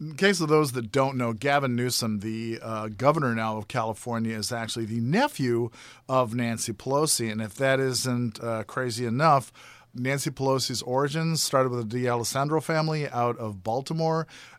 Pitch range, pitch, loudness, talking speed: 115-140 Hz, 125 Hz, -26 LUFS, 165 wpm